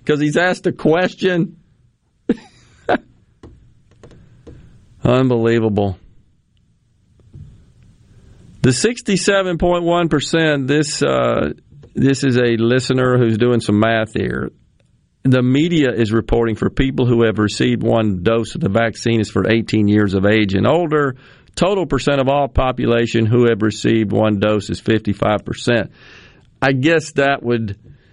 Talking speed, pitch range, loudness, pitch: 130 wpm, 110-140 Hz, -16 LUFS, 120 Hz